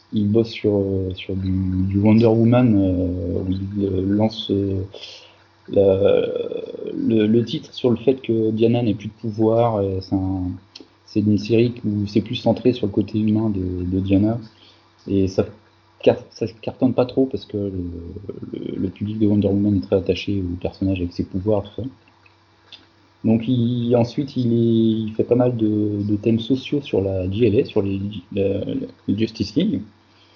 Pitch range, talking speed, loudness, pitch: 95-115 Hz, 170 wpm, -20 LUFS, 105 Hz